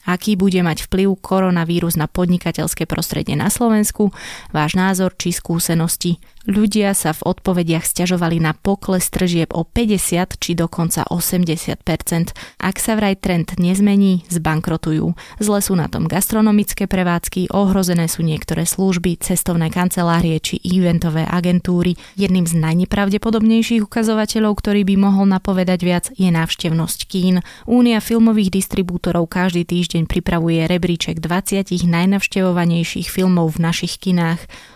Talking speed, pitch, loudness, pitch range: 125 wpm, 180 Hz, -17 LUFS, 170-195 Hz